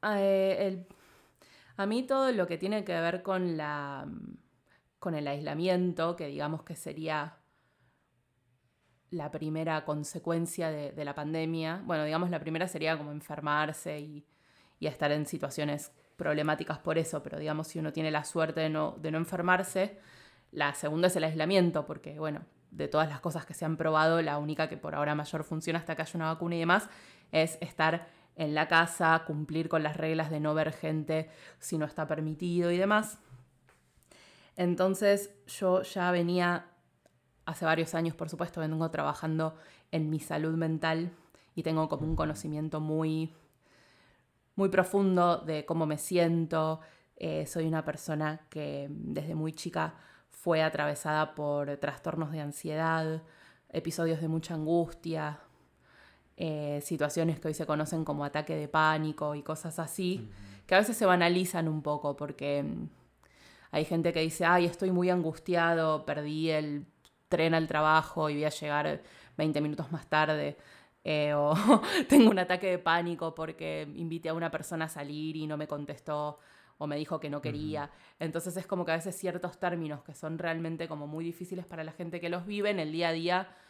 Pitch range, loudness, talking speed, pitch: 150-170 Hz, -31 LUFS, 170 wpm, 160 Hz